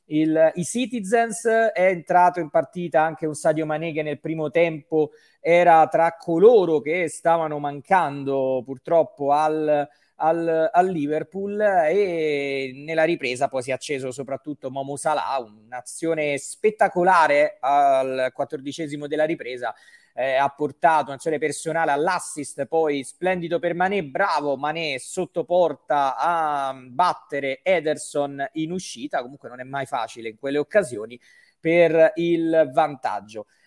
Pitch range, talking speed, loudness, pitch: 140-170 Hz, 125 wpm, -22 LUFS, 155 Hz